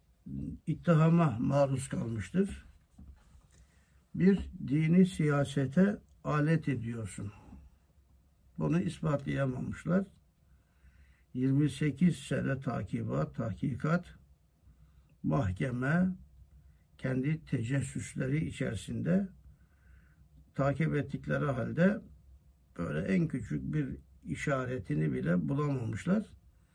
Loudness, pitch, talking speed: -32 LUFS, 130 Hz, 65 wpm